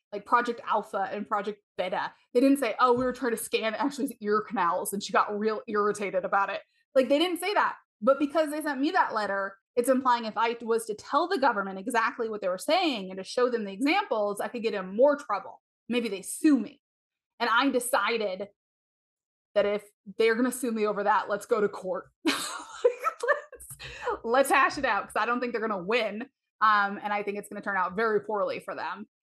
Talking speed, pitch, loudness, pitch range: 225 wpm, 225 Hz, -28 LUFS, 205-260 Hz